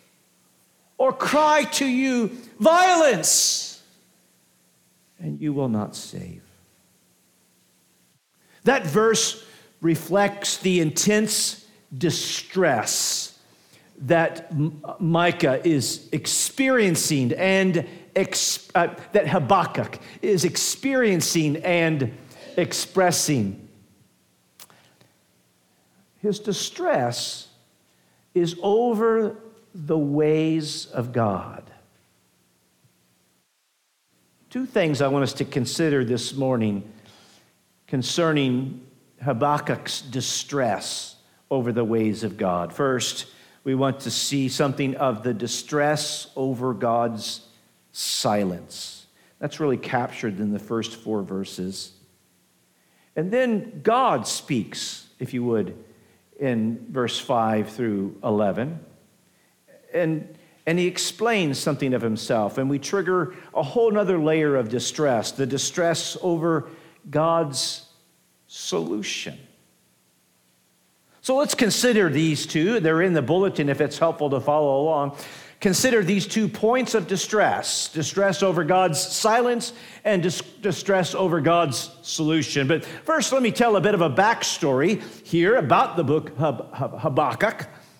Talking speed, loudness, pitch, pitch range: 105 wpm, -23 LUFS, 155 Hz, 120-185 Hz